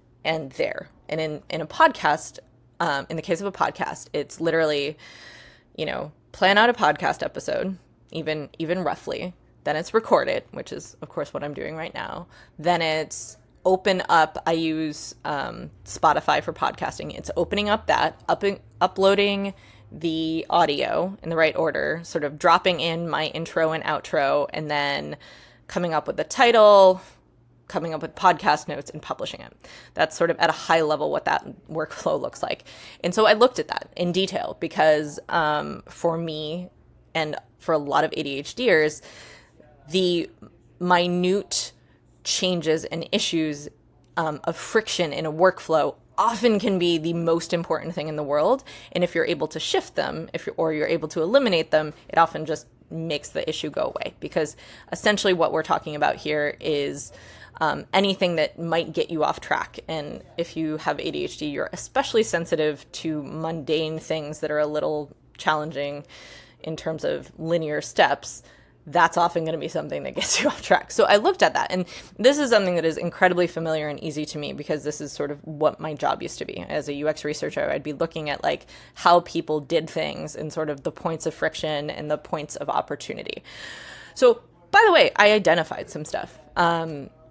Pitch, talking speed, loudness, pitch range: 160 Hz, 185 wpm, -23 LUFS, 155-180 Hz